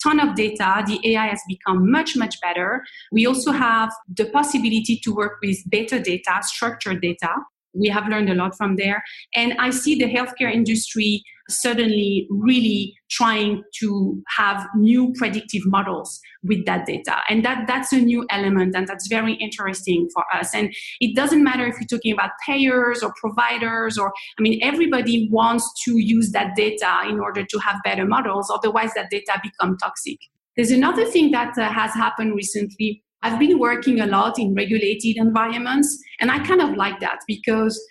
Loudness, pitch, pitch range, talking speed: -20 LUFS, 220 Hz, 205-240 Hz, 175 wpm